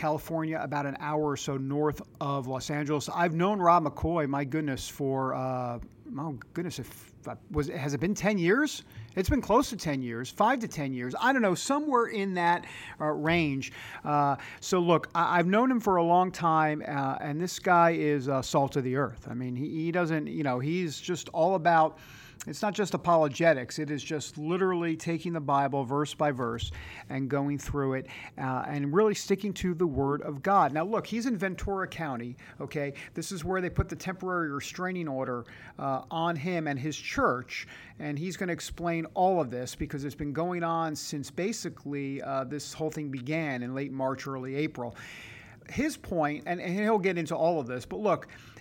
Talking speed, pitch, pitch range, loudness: 200 wpm, 150 Hz, 135-175 Hz, -29 LUFS